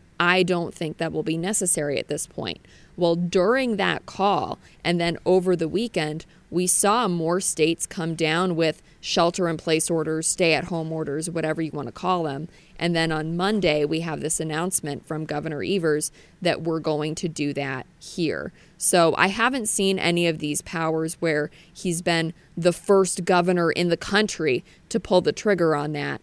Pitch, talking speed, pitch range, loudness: 170 Hz, 185 wpm, 155-180 Hz, -23 LUFS